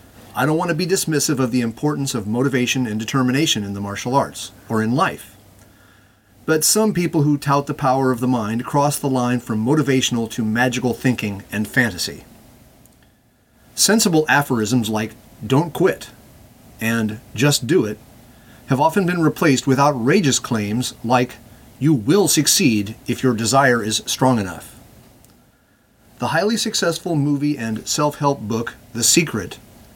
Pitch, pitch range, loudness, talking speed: 125 Hz, 110-145 Hz, -18 LUFS, 150 wpm